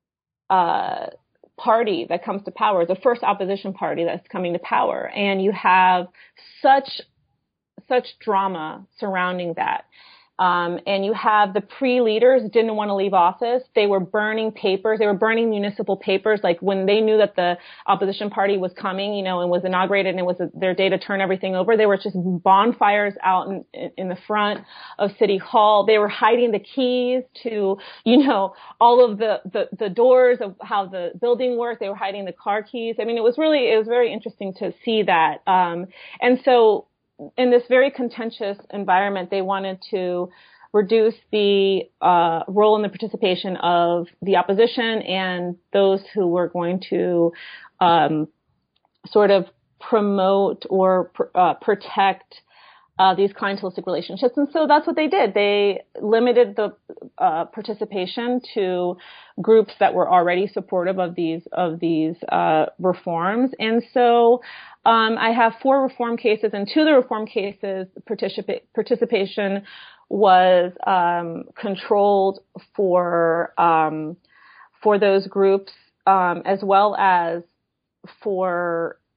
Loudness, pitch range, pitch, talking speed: -20 LUFS, 185-225 Hz, 200 Hz, 155 wpm